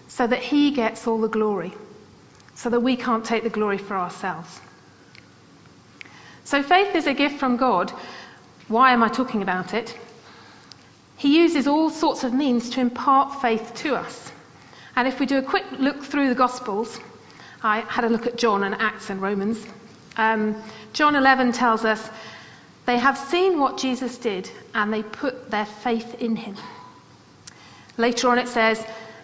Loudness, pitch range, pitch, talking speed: -22 LUFS, 220-260 Hz, 235 Hz, 170 wpm